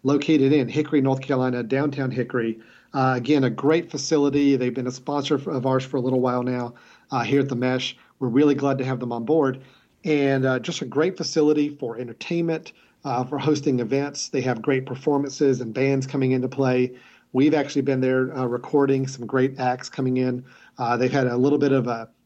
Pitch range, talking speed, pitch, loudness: 125-145 Hz, 205 wpm, 135 Hz, -23 LUFS